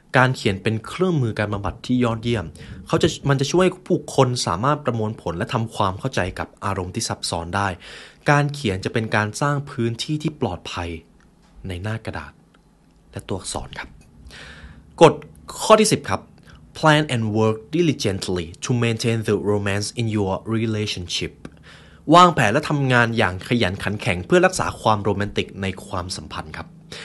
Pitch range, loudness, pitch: 95-125 Hz, -21 LUFS, 110 Hz